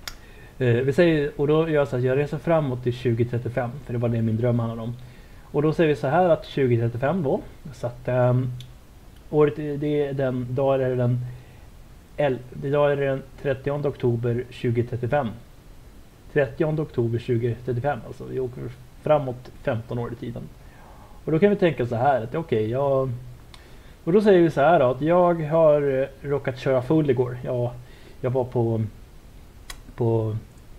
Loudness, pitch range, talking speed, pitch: -23 LUFS, 120-145 Hz, 180 wpm, 130 Hz